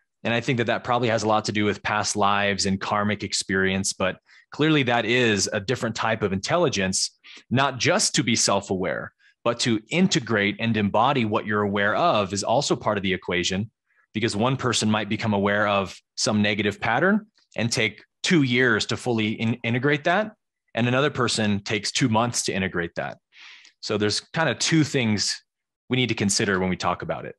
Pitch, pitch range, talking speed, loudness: 110 Hz, 105-120 Hz, 195 wpm, -23 LUFS